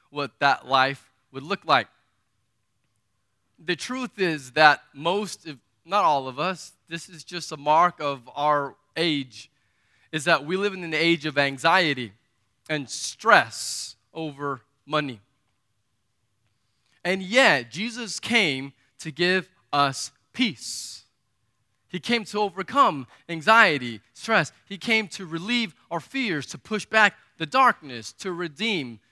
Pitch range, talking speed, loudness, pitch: 125-185 Hz, 130 wpm, -23 LUFS, 150 Hz